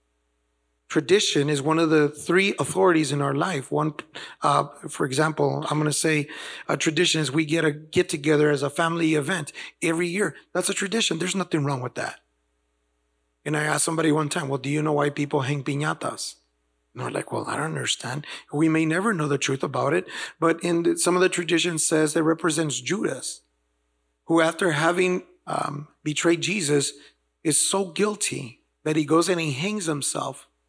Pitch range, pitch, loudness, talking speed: 145-170 Hz, 155 Hz, -24 LUFS, 190 wpm